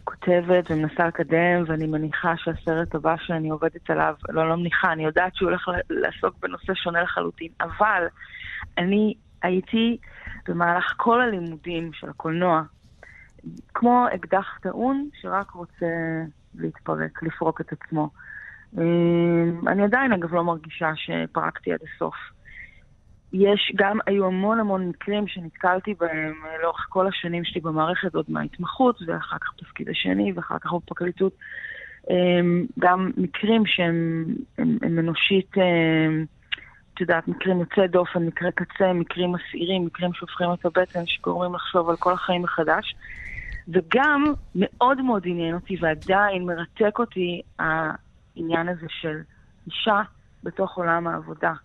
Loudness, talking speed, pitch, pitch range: -24 LUFS, 125 wpm, 175 Hz, 165-190 Hz